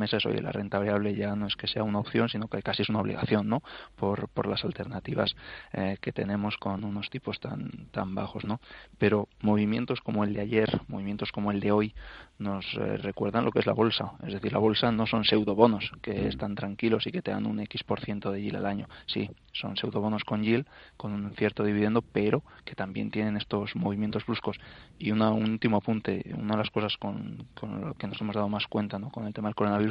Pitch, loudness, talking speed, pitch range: 105 Hz, -30 LUFS, 230 wpm, 100-110 Hz